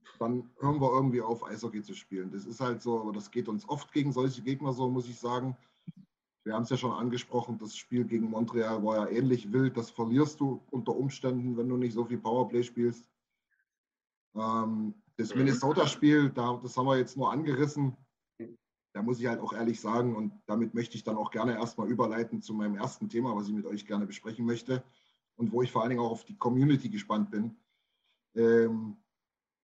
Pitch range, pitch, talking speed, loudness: 110-125 Hz, 120 Hz, 200 wpm, -31 LUFS